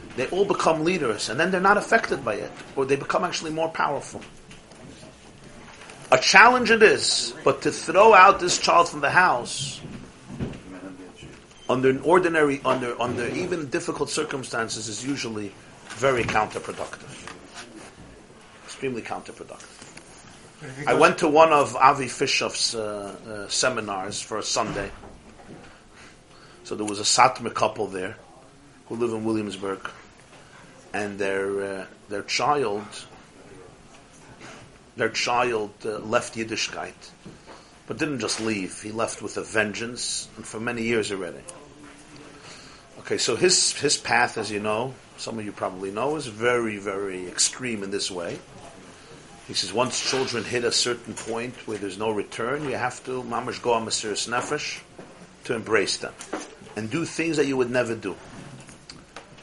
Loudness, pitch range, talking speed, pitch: -23 LUFS, 105-150 Hz, 140 wpm, 120 Hz